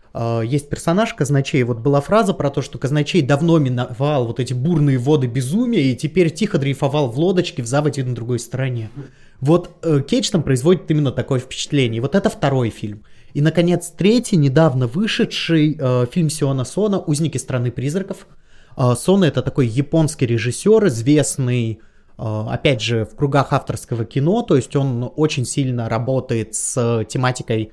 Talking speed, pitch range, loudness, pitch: 155 wpm, 125-160 Hz, -18 LUFS, 140 Hz